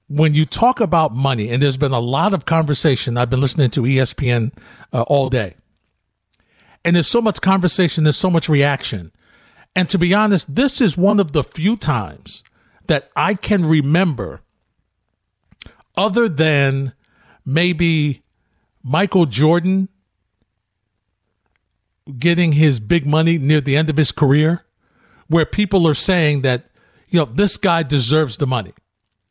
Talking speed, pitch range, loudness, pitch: 145 wpm, 115-170 Hz, -17 LUFS, 150 Hz